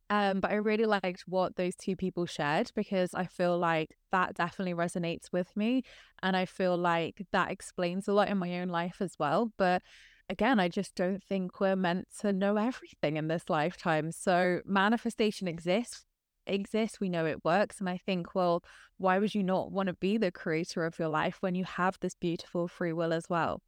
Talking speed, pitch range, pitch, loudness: 205 wpm, 175-200 Hz, 185 Hz, -31 LUFS